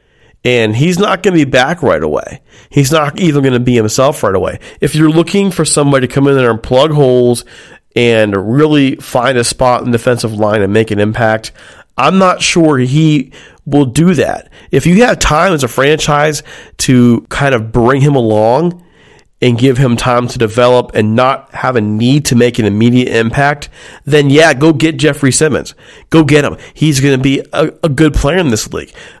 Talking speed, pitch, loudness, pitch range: 205 wpm, 135 Hz, -10 LUFS, 120-155 Hz